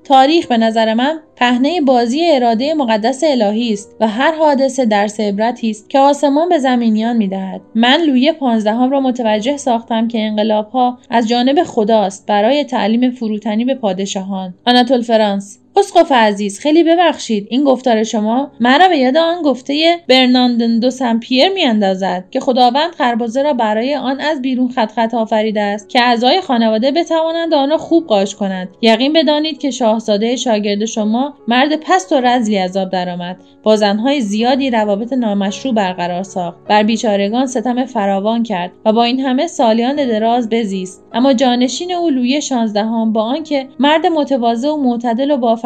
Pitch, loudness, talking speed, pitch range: 245 Hz, -14 LUFS, 165 wpm, 220-275 Hz